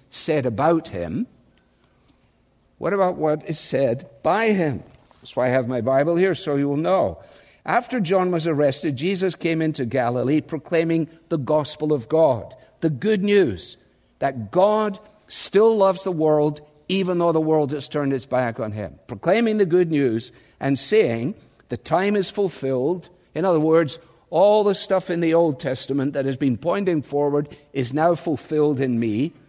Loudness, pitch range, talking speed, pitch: -21 LUFS, 140-185 Hz, 170 wpm, 155 Hz